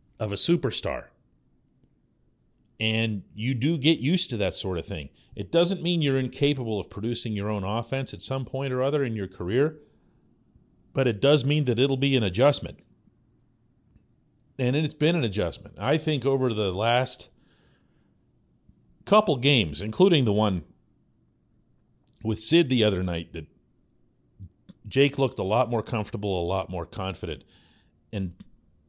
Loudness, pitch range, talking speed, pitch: -25 LUFS, 100-135 Hz, 150 wpm, 115 Hz